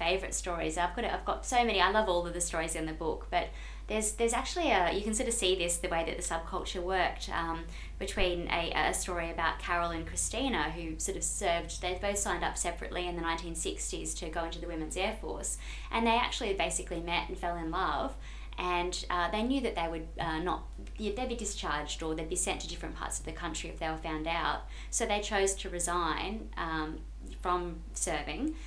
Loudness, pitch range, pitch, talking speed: -33 LUFS, 165-195 Hz, 175 Hz, 220 wpm